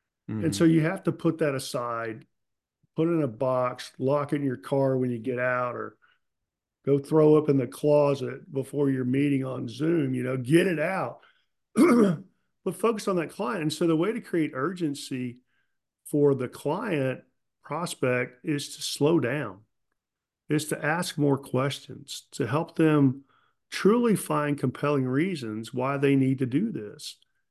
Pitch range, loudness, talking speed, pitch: 130-160 Hz, -26 LUFS, 170 wpm, 145 Hz